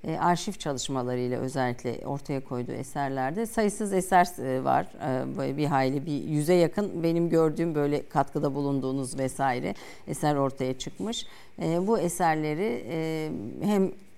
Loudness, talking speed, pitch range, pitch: -28 LUFS, 115 wpm, 135-175 Hz, 150 Hz